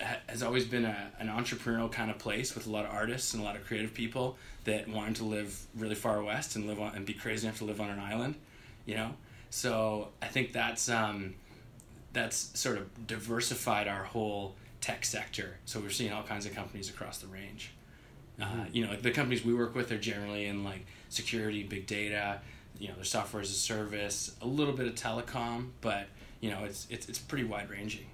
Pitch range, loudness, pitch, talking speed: 105-120 Hz, -35 LUFS, 110 Hz, 215 wpm